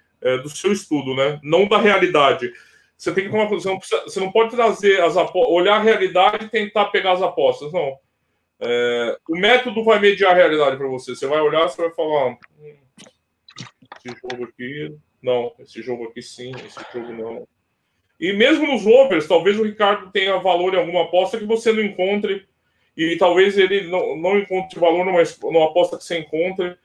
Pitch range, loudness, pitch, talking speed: 150-205 Hz, -18 LUFS, 185 Hz, 185 wpm